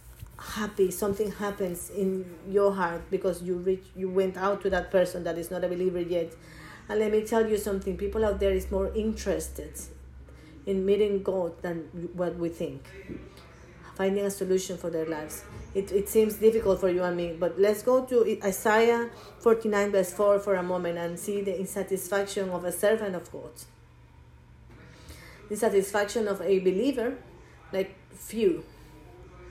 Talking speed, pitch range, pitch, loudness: 165 wpm, 175-205 Hz, 190 Hz, -28 LUFS